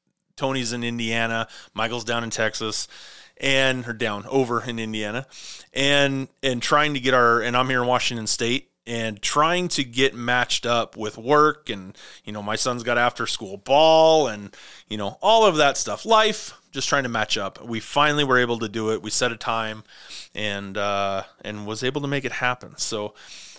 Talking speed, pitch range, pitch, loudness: 195 wpm, 110-135 Hz, 120 Hz, -22 LUFS